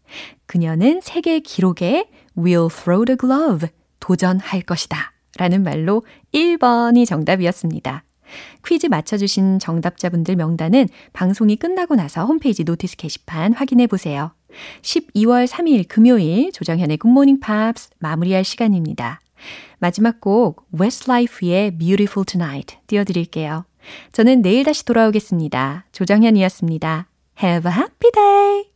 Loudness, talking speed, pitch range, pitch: -17 LUFS, 365 characters per minute, 175-245 Hz, 195 Hz